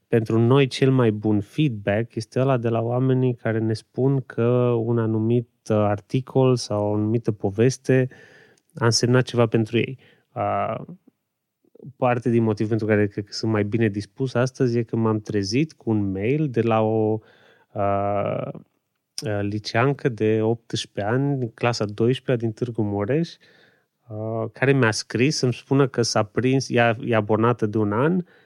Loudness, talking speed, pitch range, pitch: -22 LUFS, 160 wpm, 110-130 Hz, 115 Hz